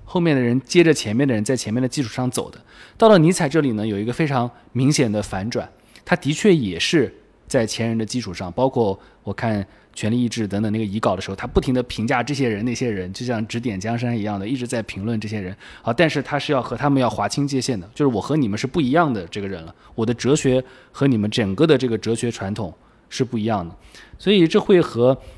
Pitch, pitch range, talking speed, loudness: 120 Hz, 105-135 Hz, 355 characters per minute, -20 LUFS